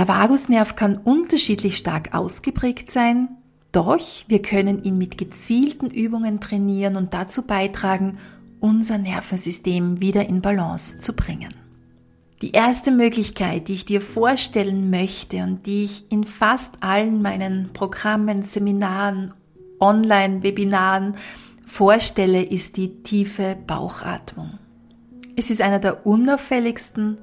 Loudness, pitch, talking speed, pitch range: -19 LUFS, 205 Hz, 115 wpm, 190-230 Hz